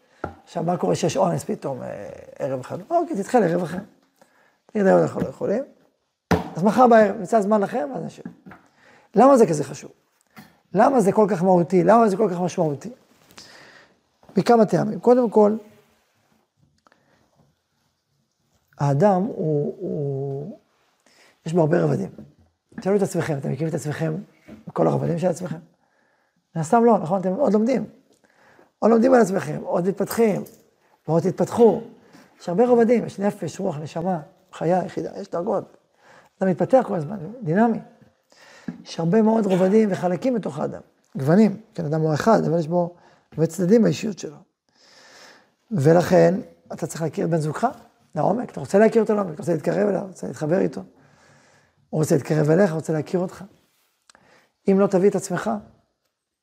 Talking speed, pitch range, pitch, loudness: 150 wpm, 170-220 Hz, 190 Hz, -21 LUFS